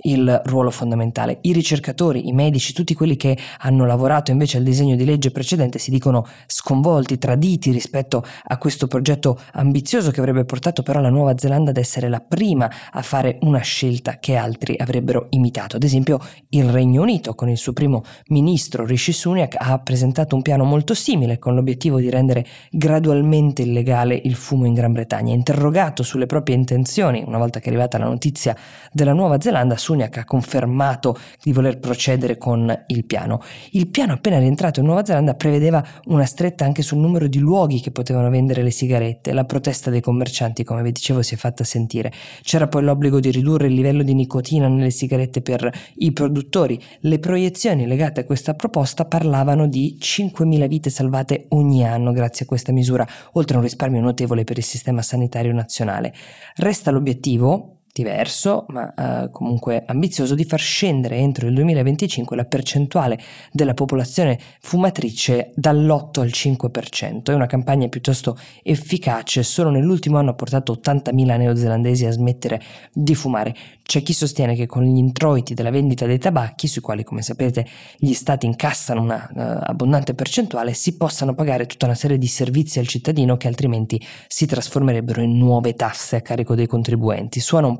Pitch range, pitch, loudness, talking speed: 125-145 Hz, 130 Hz, -19 LUFS, 175 wpm